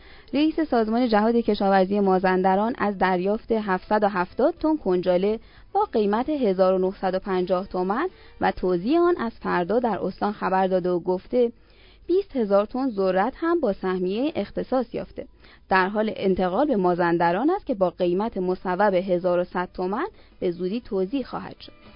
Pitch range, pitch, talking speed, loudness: 185-245 Hz, 200 Hz, 140 wpm, -23 LUFS